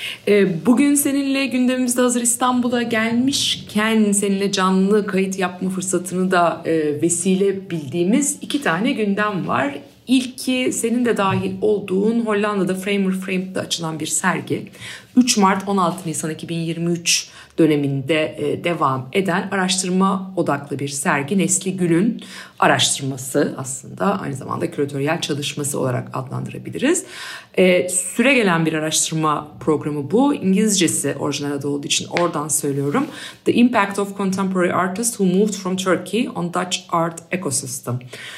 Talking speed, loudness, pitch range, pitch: 125 wpm, -19 LUFS, 160-210 Hz, 185 Hz